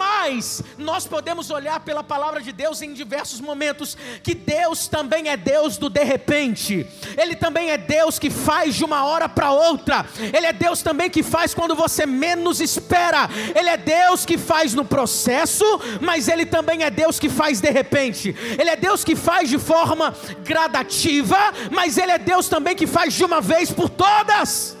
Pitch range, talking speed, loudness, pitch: 290-335 Hz, 185 wpm, -19 LUFS, 315 Hz